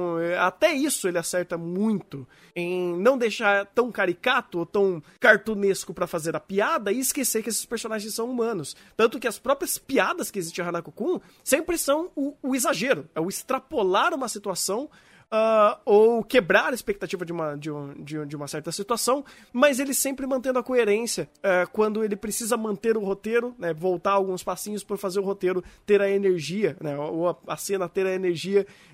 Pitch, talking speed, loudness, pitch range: 205 Hz, 190 wpm, -25 LUFS, 180-240 Hz